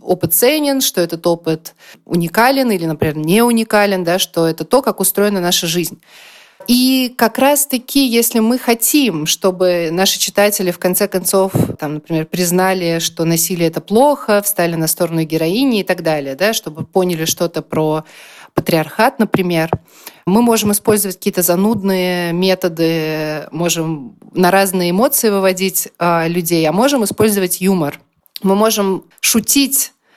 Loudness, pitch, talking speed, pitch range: -14 LUFS, 185 Hz, 140 wpm, 165-220 Hz